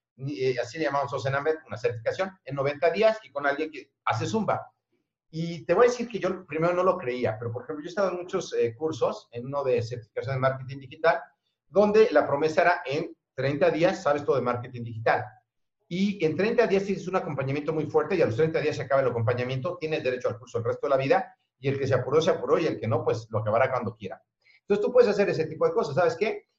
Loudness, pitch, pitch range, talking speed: -26 LUFS, 155 Hz, 135-190 Hz, 240 wpm